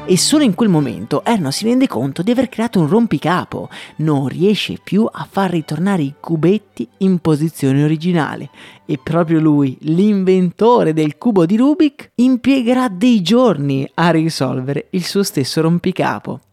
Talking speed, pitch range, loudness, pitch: 150 wpm, 155-225 Hz, -15 LUFS, 175 Hz